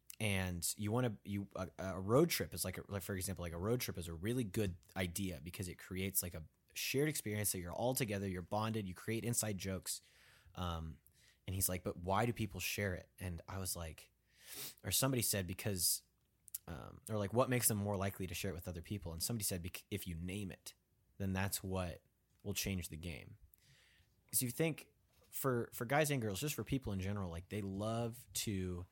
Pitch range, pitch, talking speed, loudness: 90-110 Hz, 100 Hz, 215 wpm, -40 LUFS